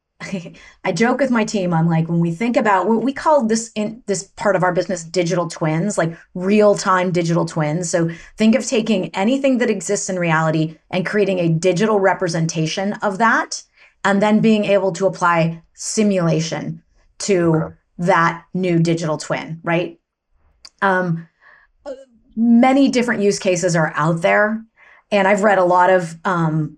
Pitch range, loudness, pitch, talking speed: 170-210 Hz, -18 LUFS, 185 Hz, 160 wpm